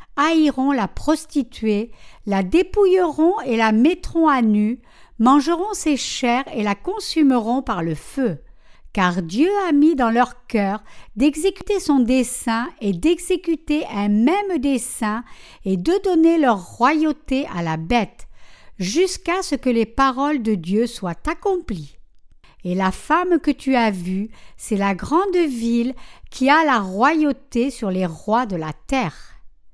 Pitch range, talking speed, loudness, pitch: 210-315 Hz, 145 wpm, -19 LUFS, 255 Hz